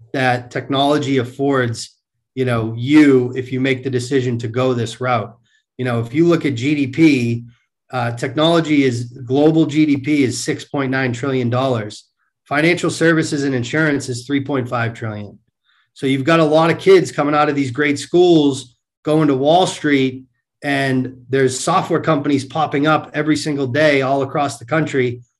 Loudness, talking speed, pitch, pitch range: -17 LUFS, 160 wpm, 135 Hz, 125-150 Hz